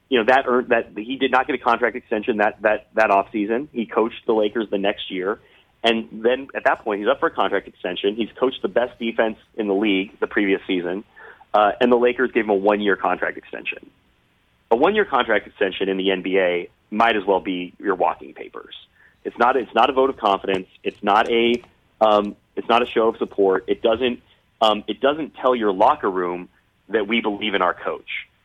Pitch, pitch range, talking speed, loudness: 110 Hz, 100-120 Hz, 215 wpm, -21 LUFS